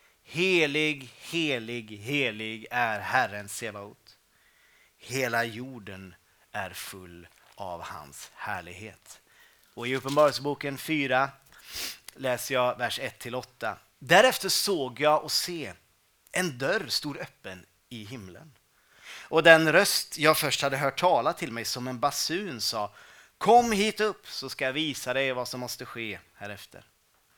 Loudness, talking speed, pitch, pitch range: -27 LUFS, 130 wpm, 125 Hz, 110-145 Hz